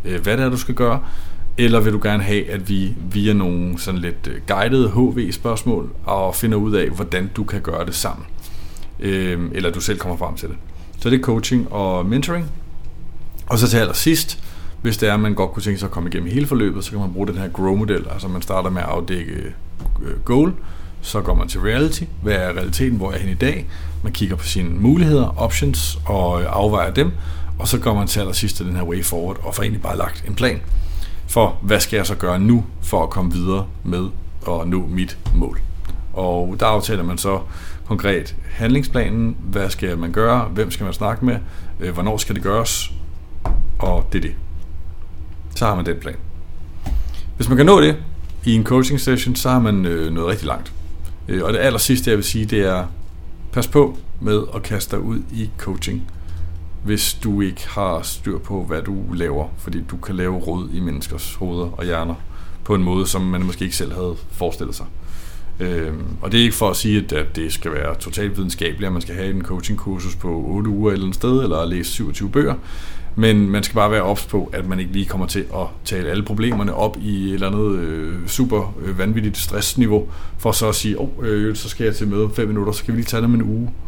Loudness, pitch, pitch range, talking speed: -20 LUFS, 95 Hz, 85-105 Hz, 215 wpm